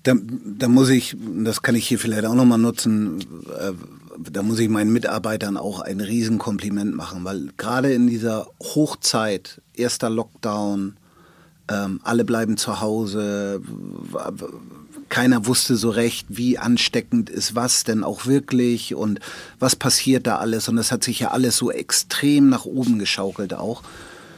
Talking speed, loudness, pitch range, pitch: 155 wpm, -21 LUFS, 105-125 Hz, 115 Hz